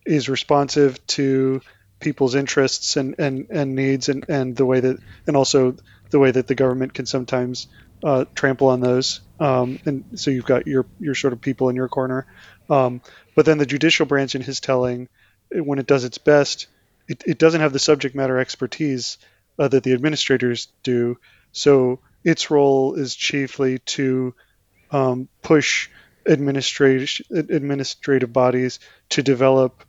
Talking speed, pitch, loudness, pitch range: 160 wpm, 135 Hz, -20 LUFS, 130-140 Hz